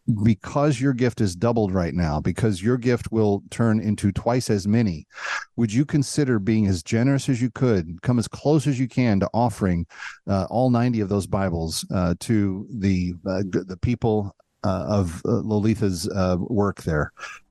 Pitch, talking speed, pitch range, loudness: 110 Hz, 180 wpm, 95-120 Hz, -23 LUFS